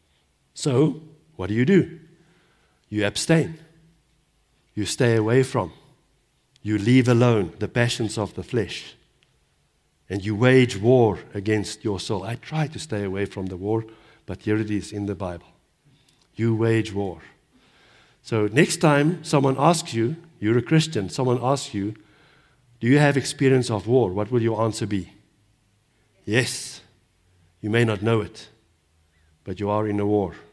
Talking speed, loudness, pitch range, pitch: 155 wpm, -23 LUFS, 105-135 Hz, 115 Hz